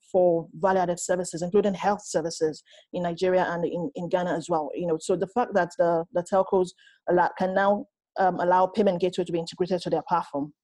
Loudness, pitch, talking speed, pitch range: -26 LUFS, 180 Hz, 195 wpm, 170-195 Hz